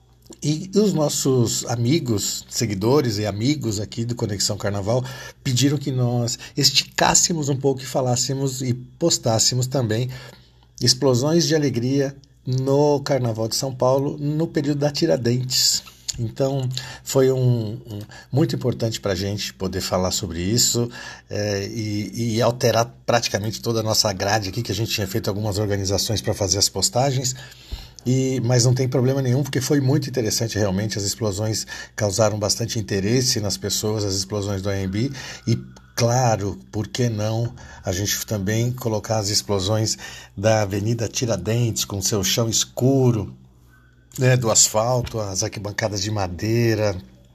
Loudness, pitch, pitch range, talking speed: -21 LUFS, 115 Hz, 105-130 Hz, 145 wpm